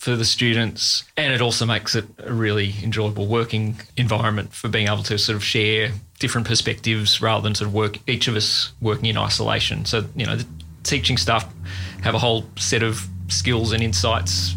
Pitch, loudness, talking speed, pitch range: 110 Hz, -20 LUFS, 195 wpm, 105-115 Hz